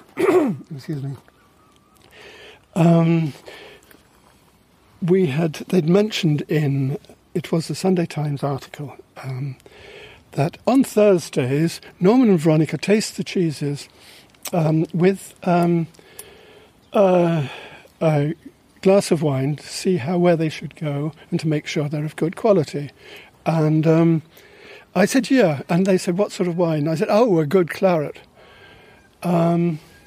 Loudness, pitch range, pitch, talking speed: -20 LUFS, 155-195 Hz, 170 Hz, 130 wpm